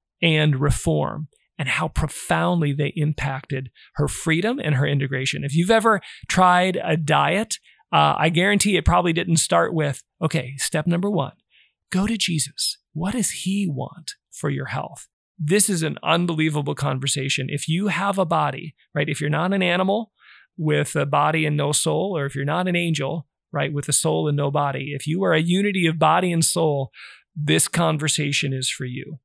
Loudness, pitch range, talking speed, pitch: -21 LUFS, 145-175 Hz, 185 wpm, 155 Hz